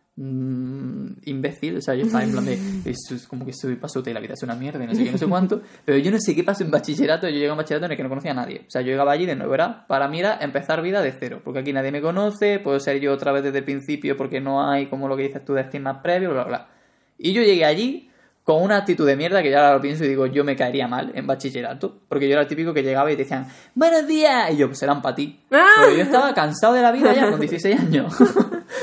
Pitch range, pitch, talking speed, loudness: 135-195 Hz, 145 Hz, 285 wpm, -20 LUFS